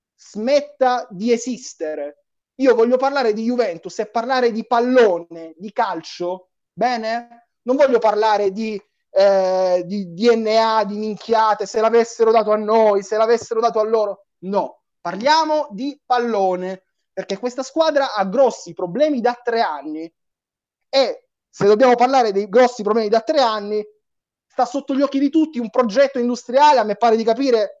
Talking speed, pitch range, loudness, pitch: 155 wpm, 205-250 Hz, -18 LUFS, 225 Hz